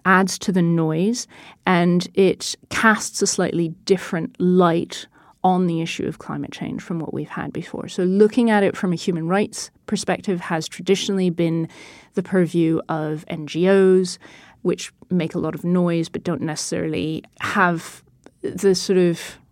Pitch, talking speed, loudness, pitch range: 180 Hz, 155 wpm, -21 LUFS, 170-195 Hz